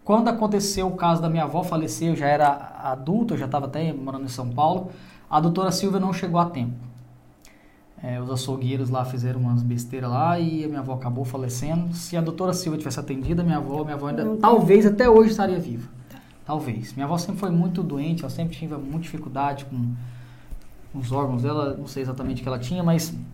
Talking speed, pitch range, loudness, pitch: 210 wpm, 130-175 Hz, -24 LUFS, 150 Hz